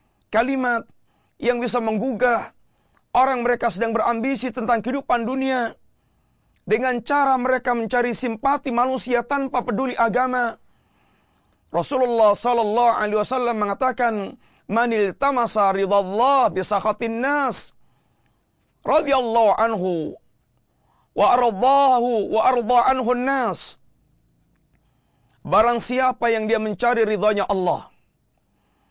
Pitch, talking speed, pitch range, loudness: 240 Hz, 95 wpm, 215-255 Hz, -21 LUFS